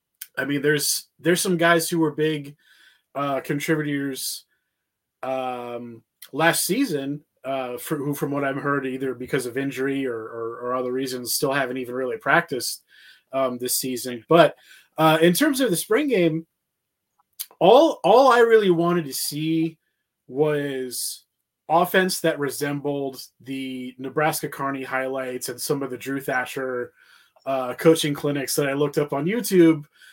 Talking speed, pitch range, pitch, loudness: 150 wpm, 130-160 Hz, 140 Hz, -22 LUFS